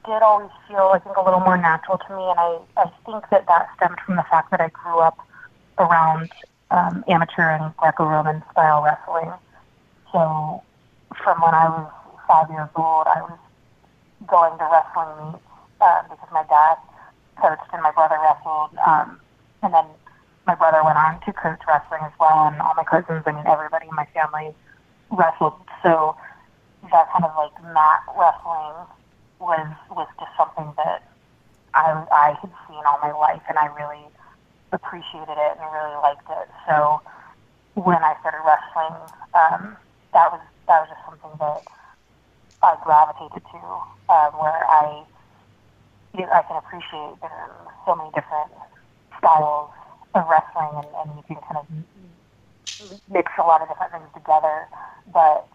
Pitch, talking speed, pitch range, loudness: 160 Hz, 165 wpm, 150-170 Hz, -19 LUFS